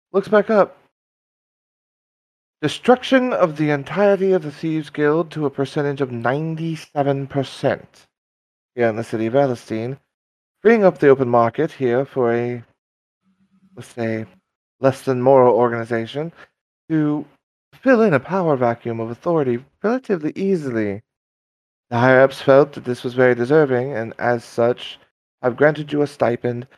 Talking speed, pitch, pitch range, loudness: 140 wpm, 135 Hz, 120-155 Hz, -19 LUFS